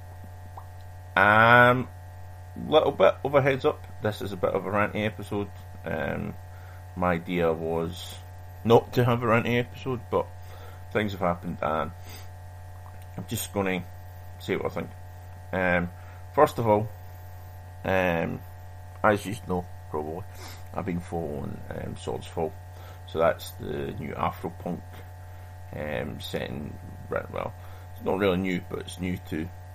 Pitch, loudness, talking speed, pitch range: 90 Hz, -27 LUFS, 140 wpm, 90-100 Hz